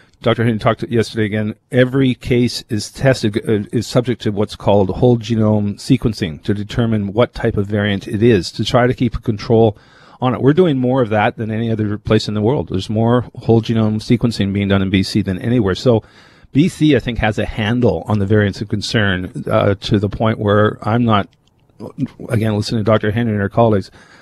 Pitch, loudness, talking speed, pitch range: 110 Hz, -16 LUFS, 210 wpm, 105-120 Hz